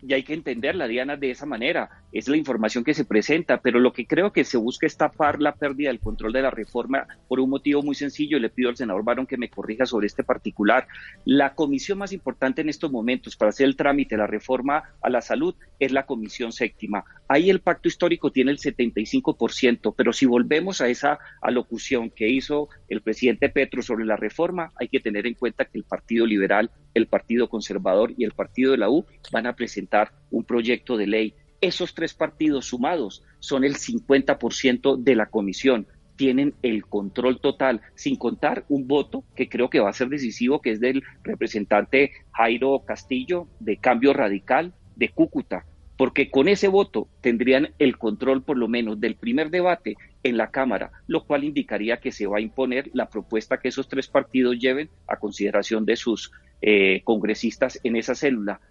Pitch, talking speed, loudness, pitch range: 130 Hz, 195 wpm, -23 LUFS, 115-140 Hz